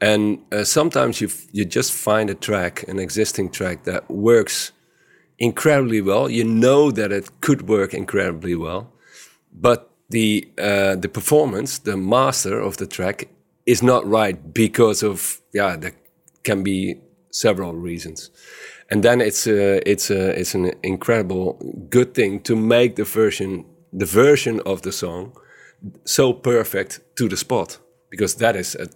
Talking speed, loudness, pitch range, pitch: 155 wpm, -19 LUFS, 95-120 Hz, 105 Hz